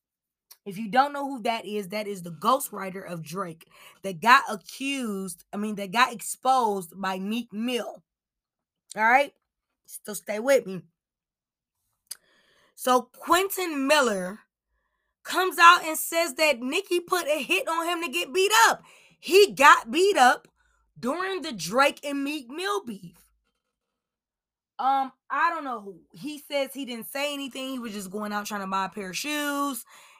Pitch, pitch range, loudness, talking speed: 265 Hz, 205-310 Hz, -24 LUFS, 165 wpm